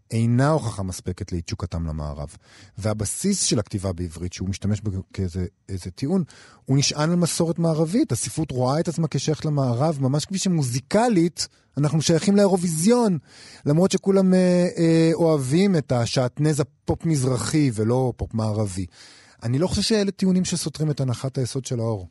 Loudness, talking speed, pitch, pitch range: -22 LUFS, 140 wpm, 135 Hz, 110-165 Hz